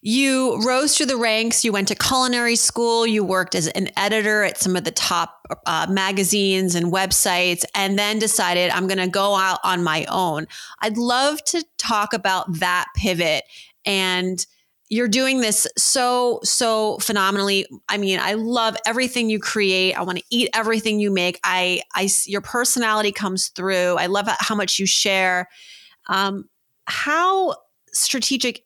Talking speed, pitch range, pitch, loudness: 165 wpm, 185-230 Hz, 205 Hz, -19 LUFS